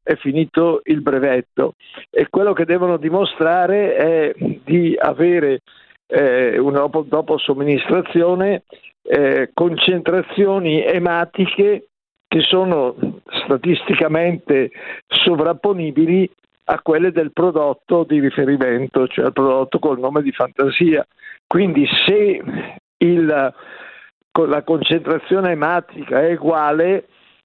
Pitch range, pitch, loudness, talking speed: 150-190 Hz, 170 Hz, -17 LUFS, 105 wpm